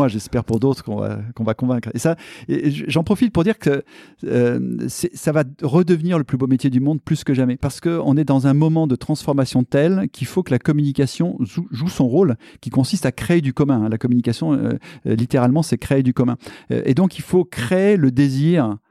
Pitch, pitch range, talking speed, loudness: 140 Hz, 125-165 Hz, 220 wpm, -19 LUFS